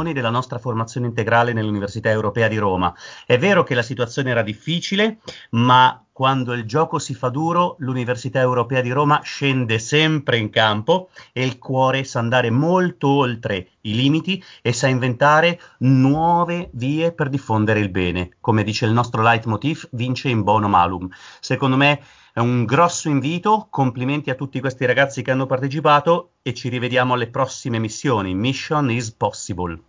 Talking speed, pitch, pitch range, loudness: 160 wpm, 130 Hz, 115-145 Hz, -19 LUFS